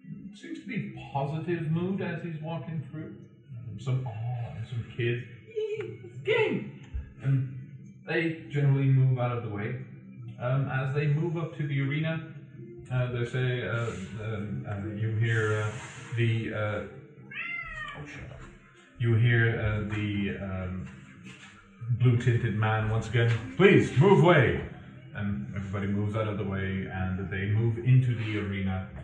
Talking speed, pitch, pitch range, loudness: 155 wpm, 120 Hz, 105-140 Hz, -29 LUFS